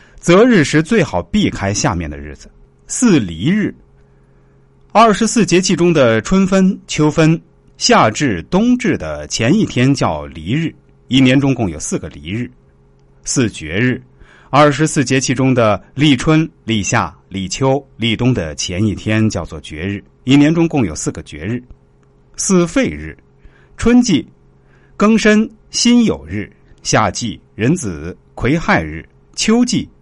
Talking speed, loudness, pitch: 200 characters per minute, -14 LUFS, 115 Hz